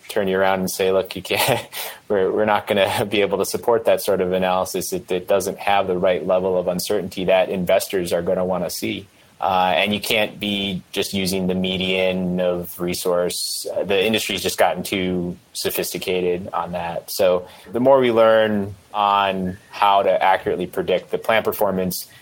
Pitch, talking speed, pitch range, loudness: 95 Hz, 190 wpm, 90-100 Hz, -20 LUFS